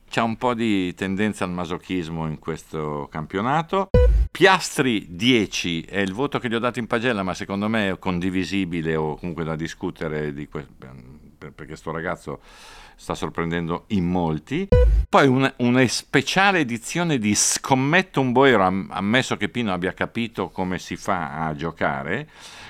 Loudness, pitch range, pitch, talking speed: -22 LUFS, 80-120 Hz, 95 Hz, 155 wpm